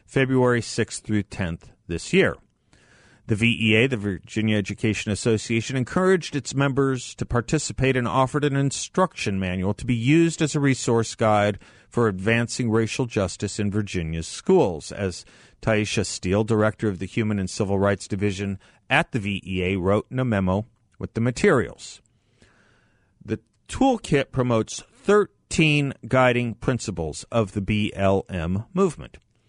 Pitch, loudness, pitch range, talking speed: 110 Hz, -23 LUFS, 100-130 Hz, 135 wpm